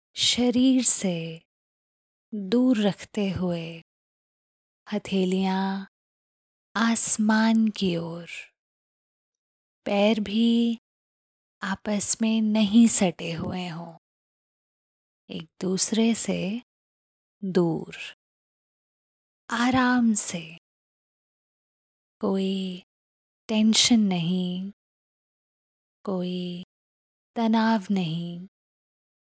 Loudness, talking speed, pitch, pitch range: -23 LUFS, 60 wpm, 195 Hz, 180-225 Hz